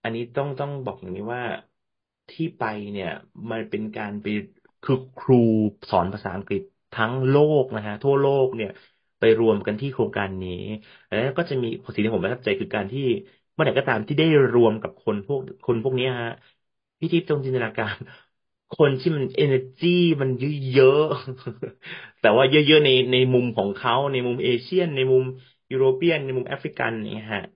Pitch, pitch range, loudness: 130 Hz, 110-140 Hz, -22 LUFS